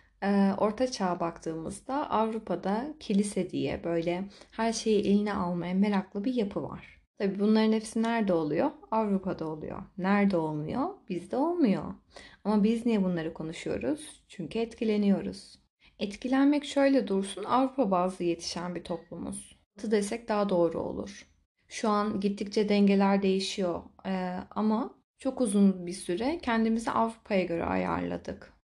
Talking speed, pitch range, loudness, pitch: 125 wpm, 175-225 Hz, -29 LUFS, 200 Hz